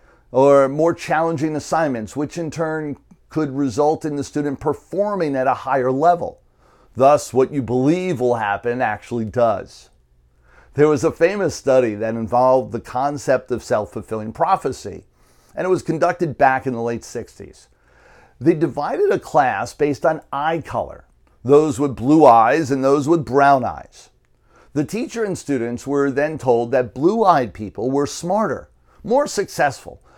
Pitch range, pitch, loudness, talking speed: 120-160 Hz, 140 Hz, -19 LUFS, 155 wpm